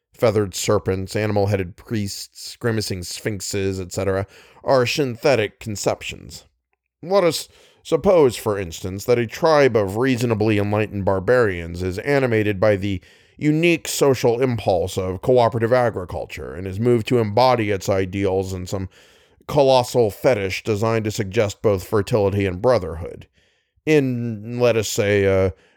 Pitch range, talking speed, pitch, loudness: 95-120 Hz, 135 wpm, 105 Hz, -20 LUFS